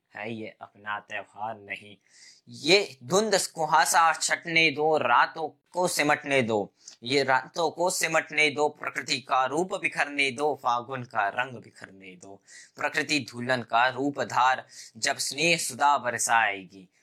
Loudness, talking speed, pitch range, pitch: -25 LUFS, 135 wpm, 115-155 Hz, 135 Hz